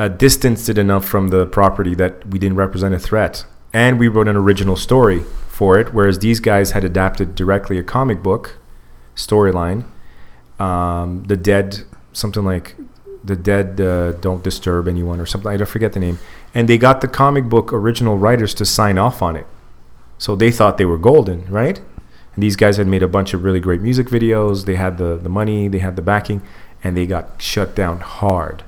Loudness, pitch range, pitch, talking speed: -16 LUFS, 90-105 Hz, 95 Hz, 200 wpm